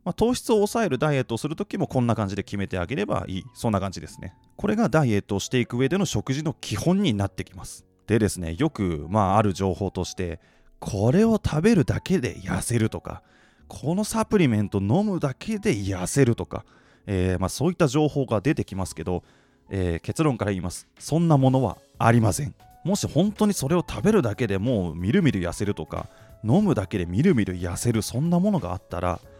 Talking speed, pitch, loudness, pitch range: 415 characters per minute, 115 Hz, -24 LUFS, 95-155 Hz